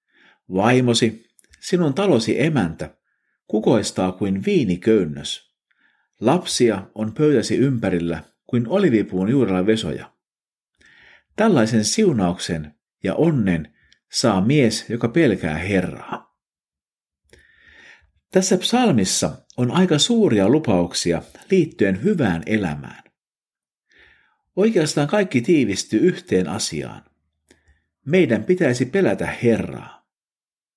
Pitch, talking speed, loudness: 115 Hz, 80 wpm, -19 LUFS